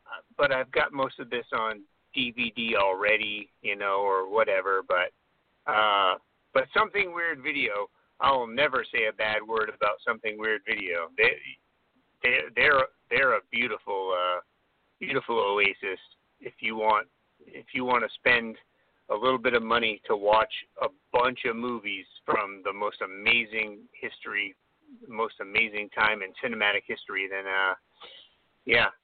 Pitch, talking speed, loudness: 120 Hz, 145 wpm, -27 LUFS